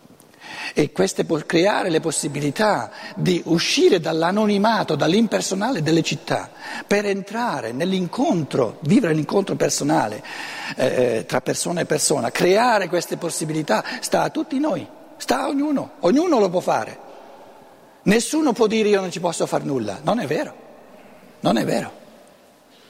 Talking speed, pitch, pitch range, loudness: 140 wpm, 195 Hz, 165-240 Hz, -21 LUFS